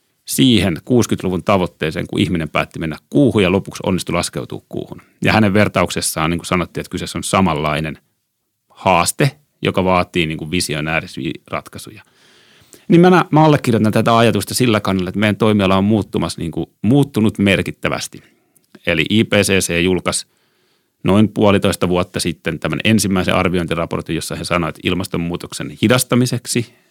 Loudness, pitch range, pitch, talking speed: -16 LUFS, 90-110 Hz, 100 Hz, 135 wpm